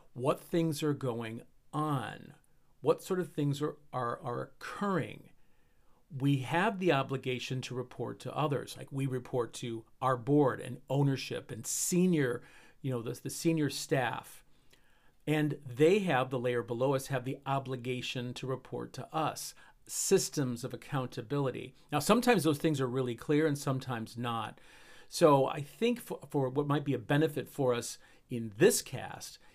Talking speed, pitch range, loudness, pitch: 160 wpm, 125-150 Hz, -33 LUFS, 135 Hz